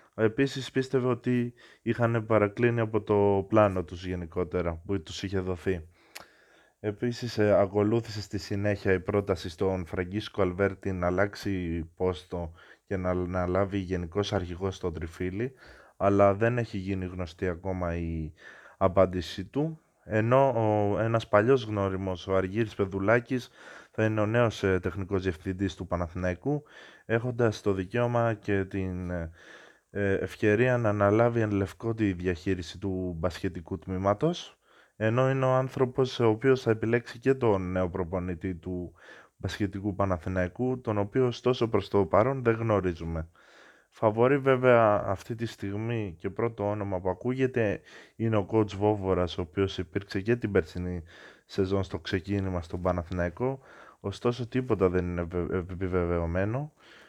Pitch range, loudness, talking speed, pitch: 90-115 Hz, -29 LUFS, 135 wpm, 100 Hz